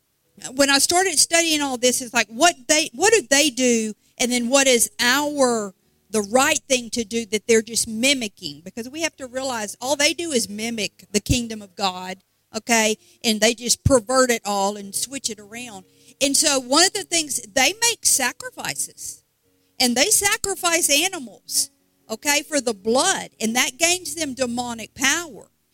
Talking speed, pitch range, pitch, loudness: 175 wpm, 220-290 Hz, 255 Hz, -19 LUFS